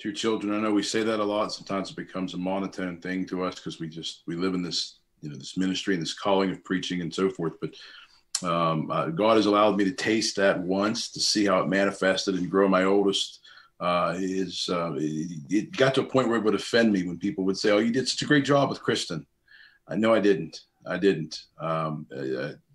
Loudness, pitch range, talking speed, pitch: -26 LUFS, 90-105 Hz, 245 wpm, 95 Hz